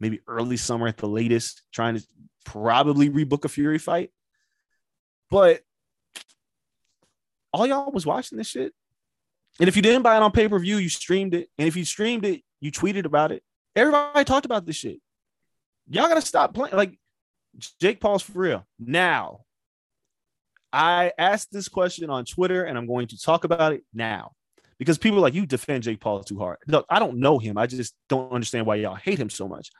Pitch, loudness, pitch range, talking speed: 160 Hz, -23 LUFS, 120-200 Hz, 190 wpm